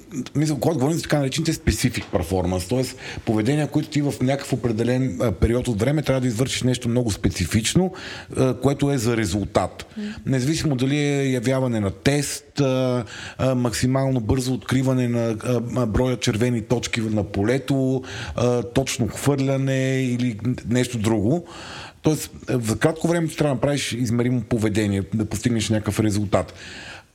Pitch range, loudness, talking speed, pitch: 115-135 Hz, -22 LUFS, 135 wpm, 125 Hz